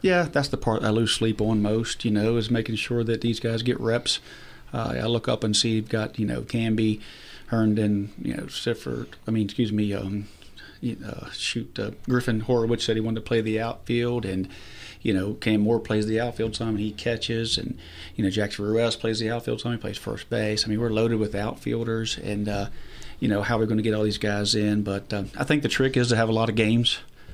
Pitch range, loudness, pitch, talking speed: 105-115 Hz, -25 LUFS, 110 Hz, 240 wpm